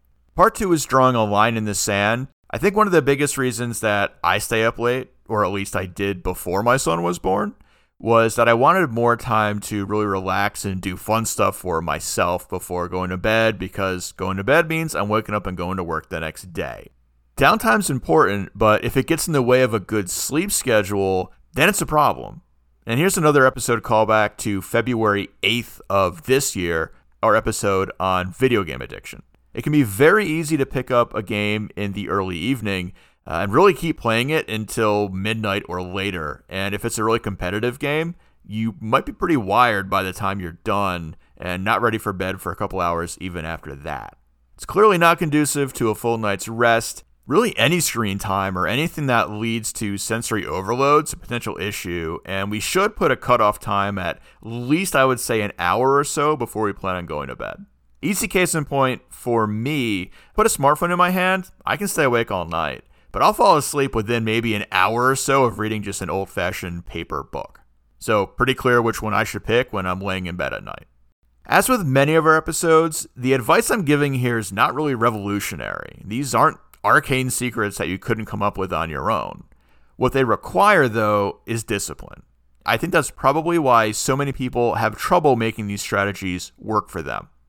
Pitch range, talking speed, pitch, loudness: 95-130 Hz, 205 wpm, 110 Hz, -20 LUFS